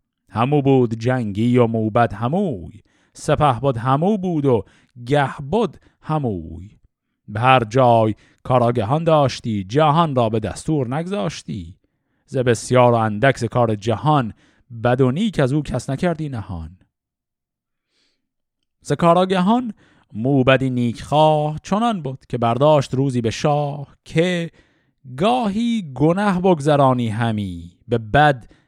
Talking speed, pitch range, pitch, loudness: 115 wpm, 115-155 Hz, 135 Hz, -19 LUFS